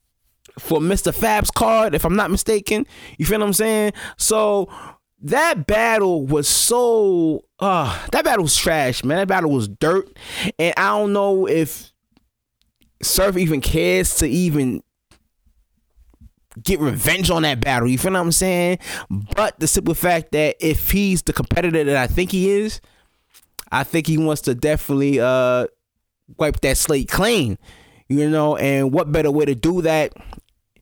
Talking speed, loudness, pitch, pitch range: 160 wpm, -18 LUFS, 165 Hz, 145-195 Hz